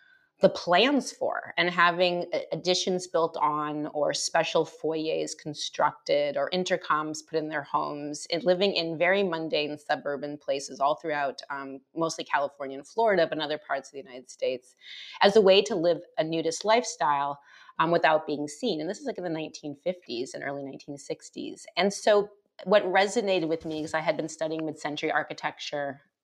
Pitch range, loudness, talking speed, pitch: 150-185 Hz, -27 LUFS, 175 wpm, 160 Hz